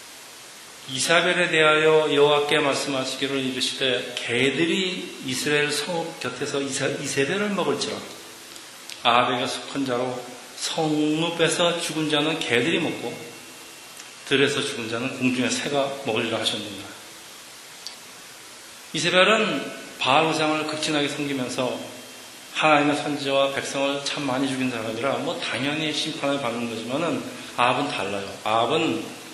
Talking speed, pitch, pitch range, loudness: 280 characters per minute, 140 Hz, 130-155 Hz, -23 LUFS